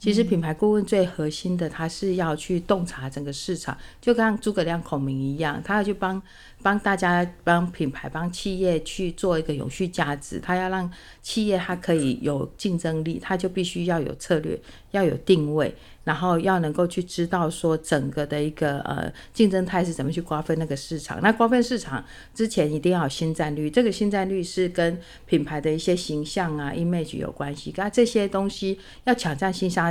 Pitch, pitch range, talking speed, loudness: 175 Hz, 155-190 Hz, 300 characters per minute, -25 LUFS